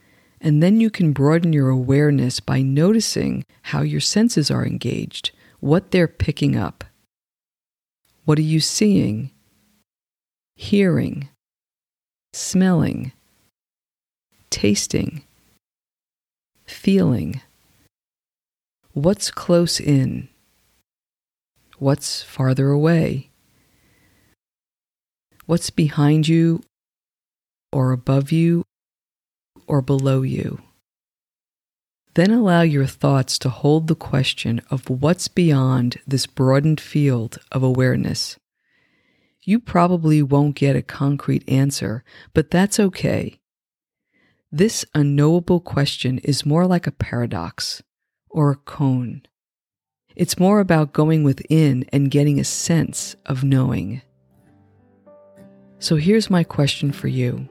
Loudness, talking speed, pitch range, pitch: -19 LUFS, 100 wpm, 130-165 Hz, 145 Hz